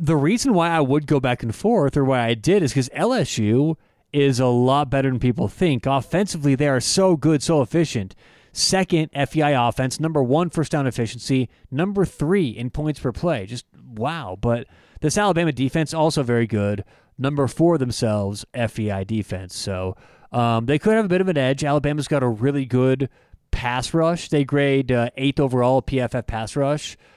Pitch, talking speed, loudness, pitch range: 135 Hz, 185 wpm, -21 LUFS, 120-155 Hz